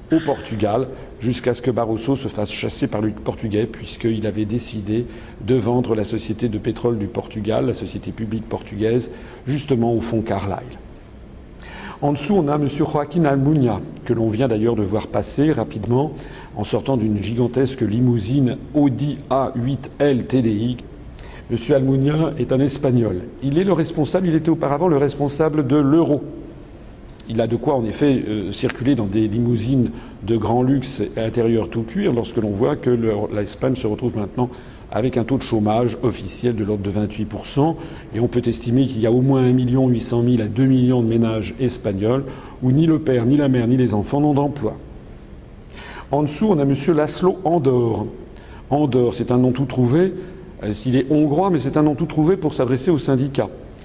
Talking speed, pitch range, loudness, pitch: 185 wpm, 110-140 Hz, -20 LUFS, 125 Hz